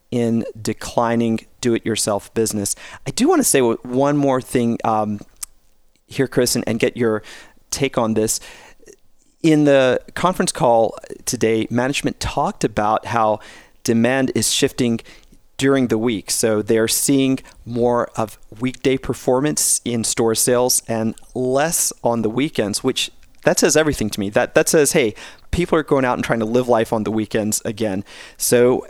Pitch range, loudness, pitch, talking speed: 110-130 Hz, -18 LUFS, 115 Hz, 160 wpm